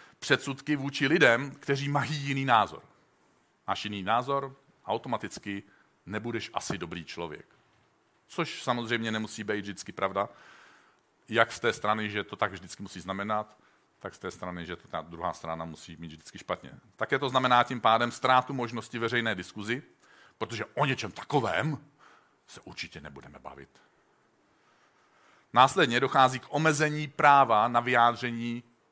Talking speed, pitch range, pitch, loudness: 140 wpm, 100-130 Hz, 115 Hz, -28 LUFS